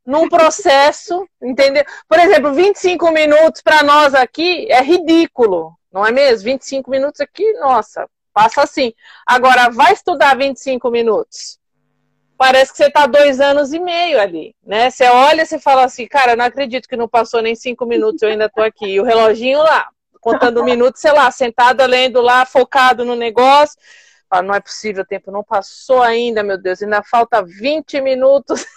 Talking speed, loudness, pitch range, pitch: 175 wpm, -12 LUFS, 235-295 Hz, 260 Hz